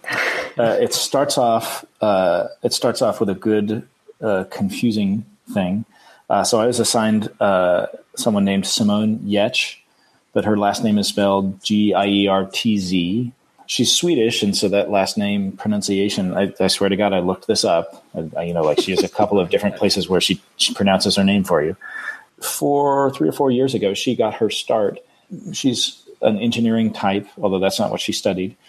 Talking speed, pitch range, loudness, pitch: 195 wpm, 100-125 Hz, -19 LUFS, 105 Hz